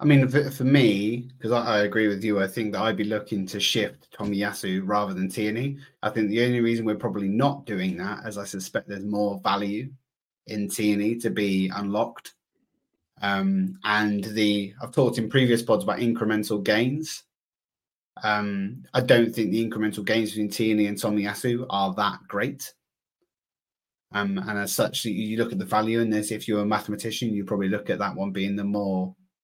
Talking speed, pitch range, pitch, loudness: 190 wpm, 100-115 Hz, 105 Hz, -25 LUFS